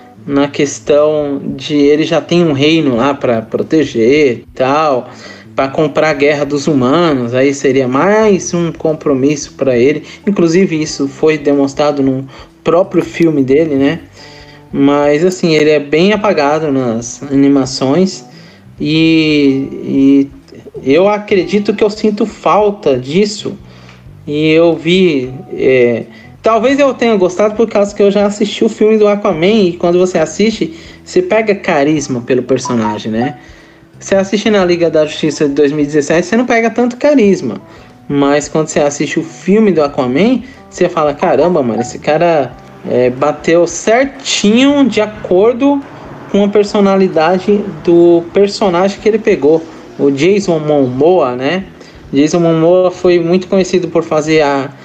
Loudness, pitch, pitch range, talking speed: -11 LUFS, 160 Hz, 140-200 Hz, 145 wpm